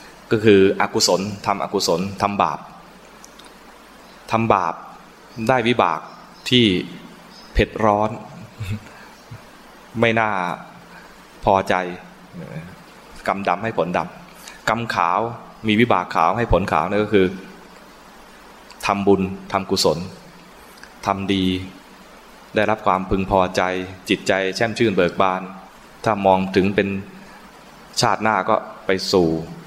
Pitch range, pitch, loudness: 95-105 Hz, 100 Hz, -20 LUFS